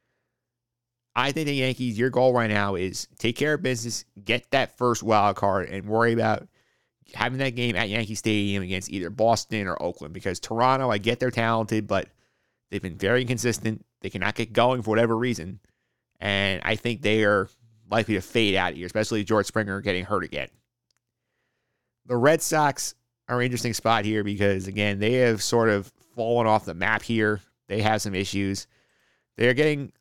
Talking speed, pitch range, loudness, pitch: 180 wpm, 100-120 Hz, -25 LUFS, 110 Hz